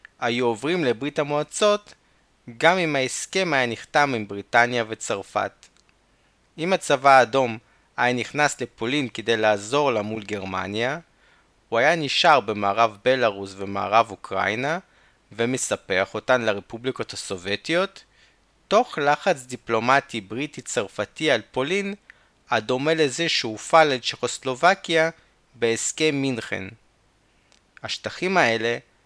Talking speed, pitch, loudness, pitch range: 100 wpm, 125 Hz, -23 LUFS, 110-150 Hz